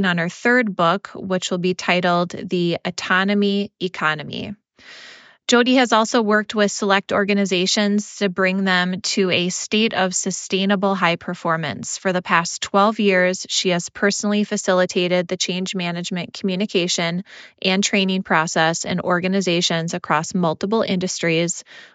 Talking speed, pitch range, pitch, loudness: 135 wpm, 180-205 Hz, 185 Hz, -19 LUFS